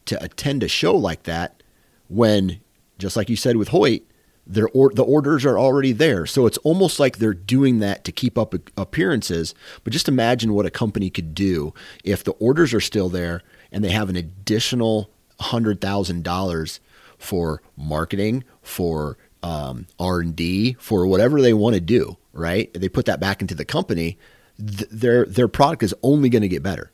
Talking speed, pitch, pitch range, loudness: 180 wpm, 105 Hz, 90-120 Hz, -20 LUFS